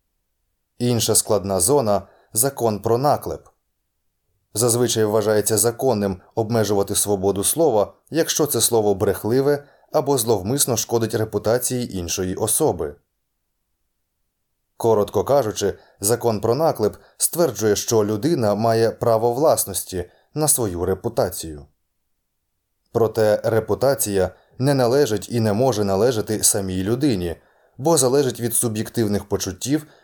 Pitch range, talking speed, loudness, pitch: 100-120 Hz, 100 wpm, -20 LUFS, 110 Hz